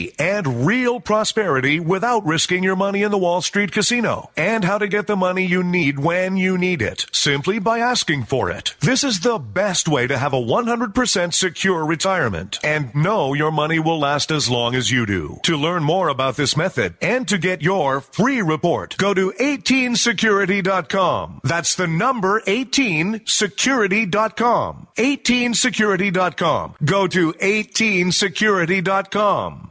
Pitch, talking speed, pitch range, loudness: 190 Hz, 150 wpm, 160-215 Hz, -18 LUFS